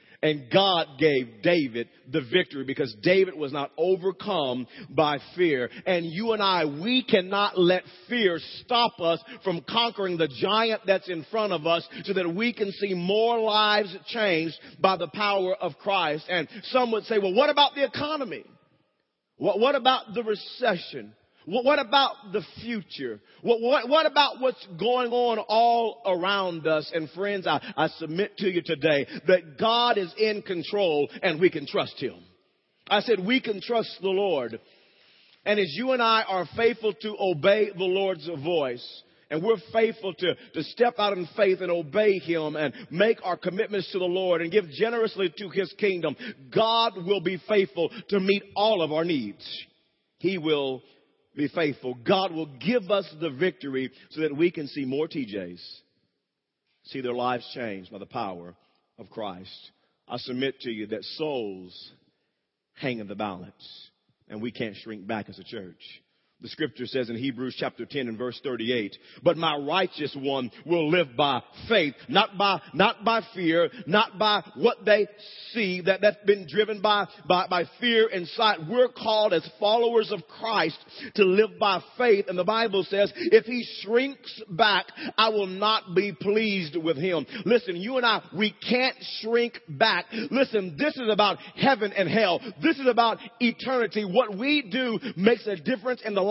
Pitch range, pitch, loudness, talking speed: 160-220 Hz, 195 Hz, -25 LUFS, 175 wpm